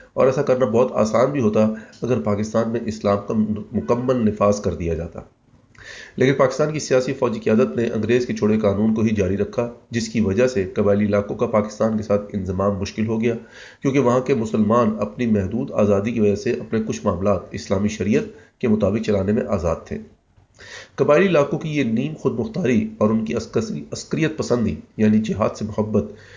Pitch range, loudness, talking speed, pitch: 100-120 Hz, -20 LUFS, 190 wpm, 110 Hz